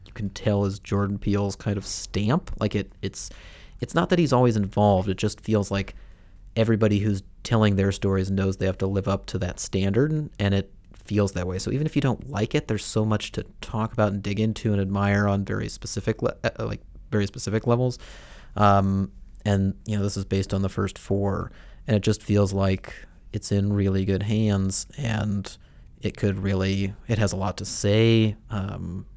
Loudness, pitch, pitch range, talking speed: -25 LUFS, 100 Hz, 95-110 Hz, 200 wpm